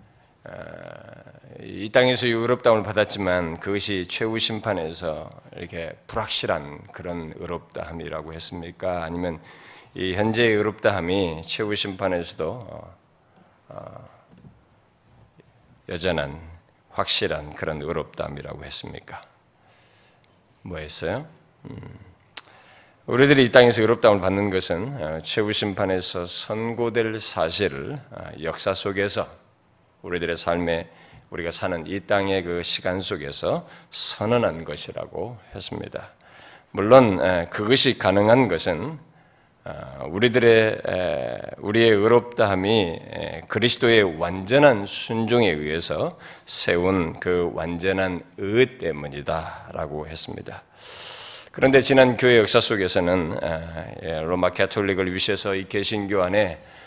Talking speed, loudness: 245 characters per minute, -22 LUFS